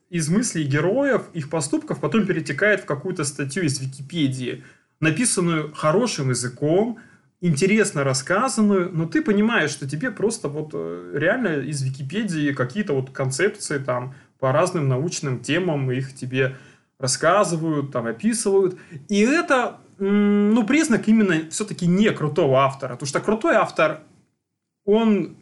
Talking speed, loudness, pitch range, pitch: 125 wpm, -22 LUFS, 140-205 Hz, 165 Hz